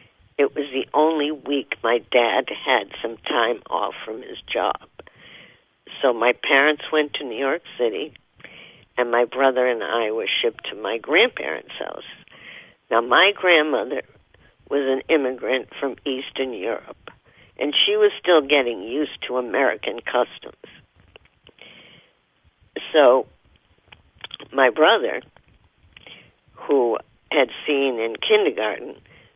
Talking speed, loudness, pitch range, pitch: 120 wpm, -21 LUFS, 130-160 Hz, 140 Hz